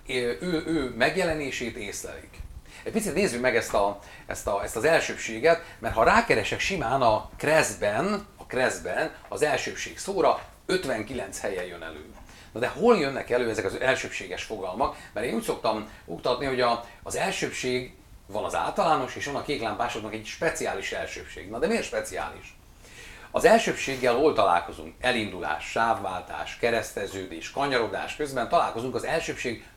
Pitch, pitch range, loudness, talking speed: 120 Hz, 100-135 Hz, -27 LUFS, 150 wpm